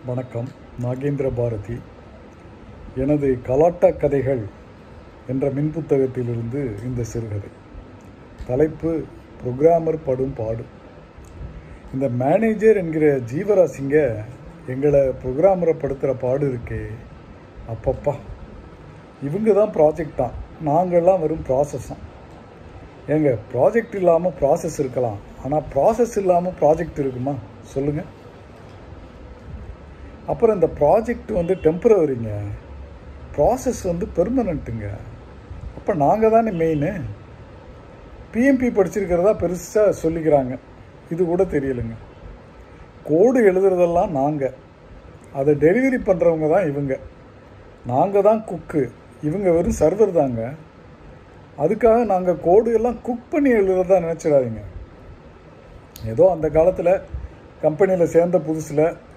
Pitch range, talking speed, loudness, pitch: 115-175 Hz, 90 wpm, -20 LUFS, 145 Hz